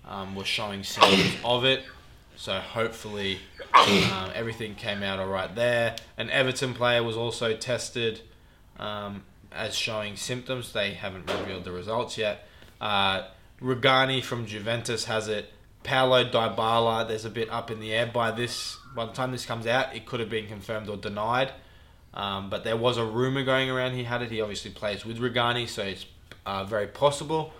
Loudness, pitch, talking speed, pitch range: -27 LUFS, 115 Hz, 175 wpm, 100-120 Hz